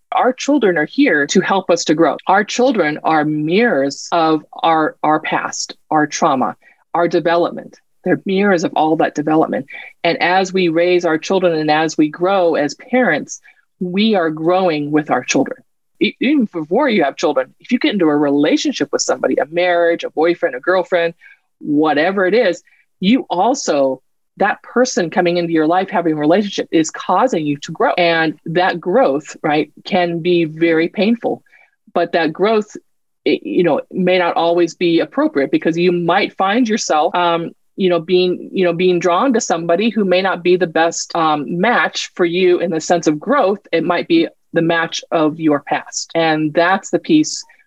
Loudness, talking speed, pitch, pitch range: -16 LUFS, 180 wpm, 175 Hz, 165-200 Hz